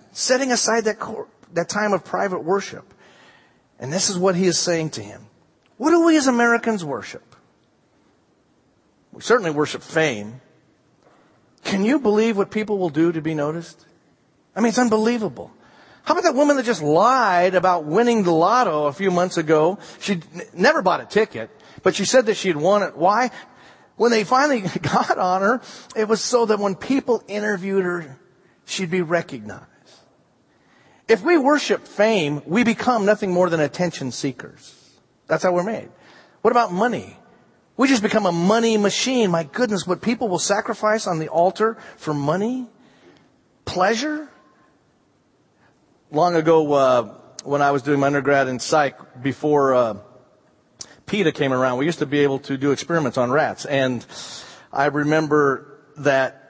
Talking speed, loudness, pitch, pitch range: 165 wpm, -20 LUFS, 185 Hz, 150-225 Hz